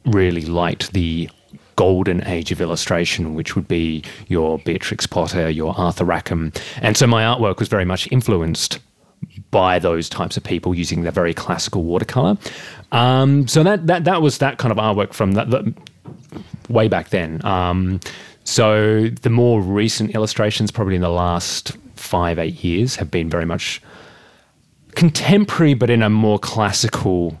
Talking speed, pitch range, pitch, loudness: 160 wpm, 85-120 Hz, 105 Hz, -18 LUFS